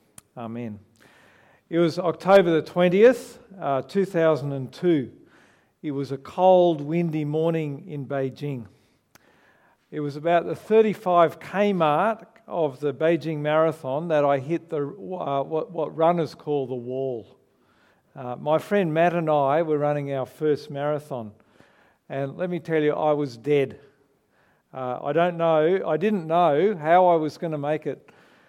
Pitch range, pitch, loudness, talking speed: 140-170 Hz, 155 Hz, -23 LUFS, 145 wpm